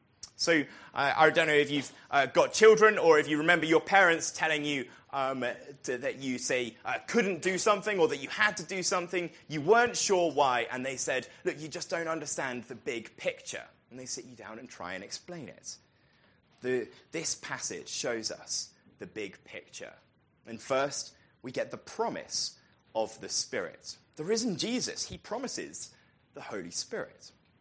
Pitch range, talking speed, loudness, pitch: 135-185 Hz, 185 wpm, -29 LUFS, 155 Hz